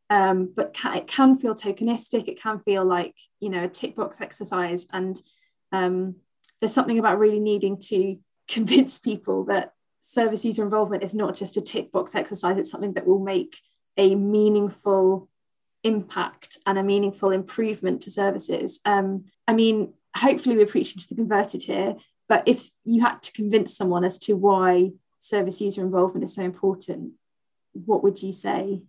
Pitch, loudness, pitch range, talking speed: 200 Hz, -23 LUFS, 190-220 Hz, 170 wpm